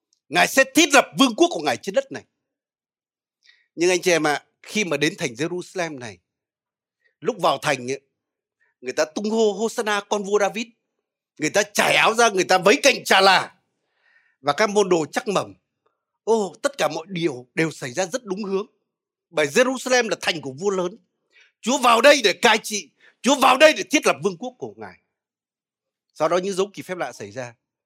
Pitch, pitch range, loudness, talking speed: 205 Hz, 165-245 Hz, -20 LUFS, 205 wpm